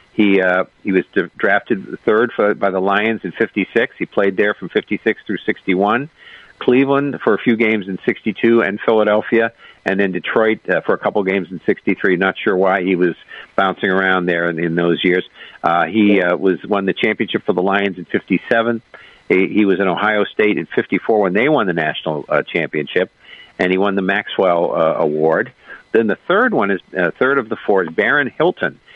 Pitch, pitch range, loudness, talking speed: 100 Hz, 90-110 Hz, -17 LUFS, 200 wpm